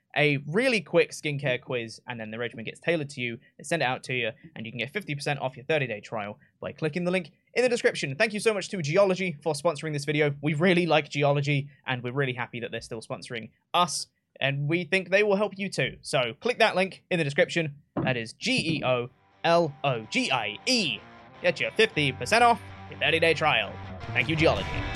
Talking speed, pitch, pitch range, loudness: 230 wpm, 150 Hz, 125-180 Hz, -26 LUFS